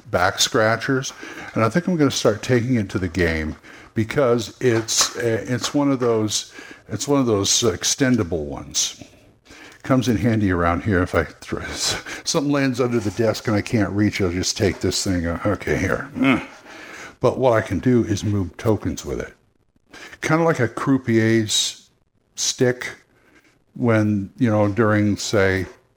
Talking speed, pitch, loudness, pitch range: 165 wpm, 110 Hz, -20 LUFS, 100-125 Hz